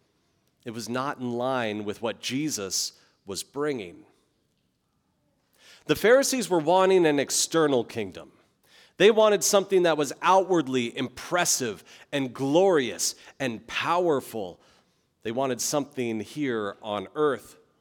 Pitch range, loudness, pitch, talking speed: 120-165 Hz, -25 LUFS, 135 Hz, 115 wpm